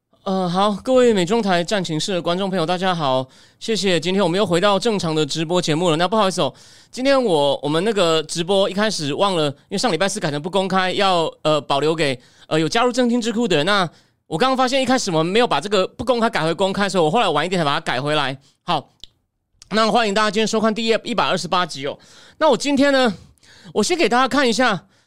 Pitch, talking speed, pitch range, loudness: 190 Hz, 355 characters per minute, 160-225 Hz, -19 LUFS